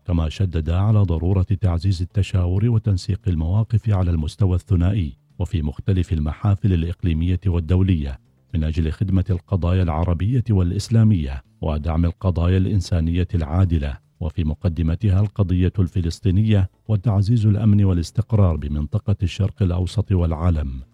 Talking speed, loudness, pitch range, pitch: 105 wpm, -21 LUFS, 85-100 Hz, 90 Hz